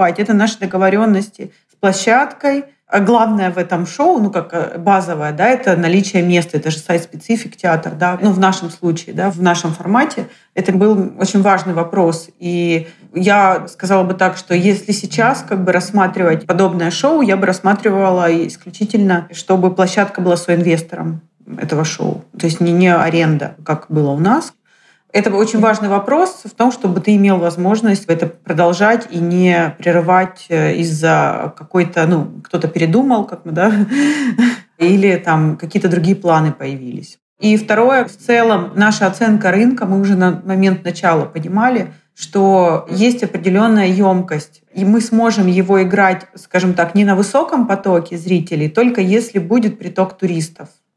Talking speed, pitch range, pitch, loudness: 155 wpm, 170-210 Hz, 190 Hz, -14 LUFS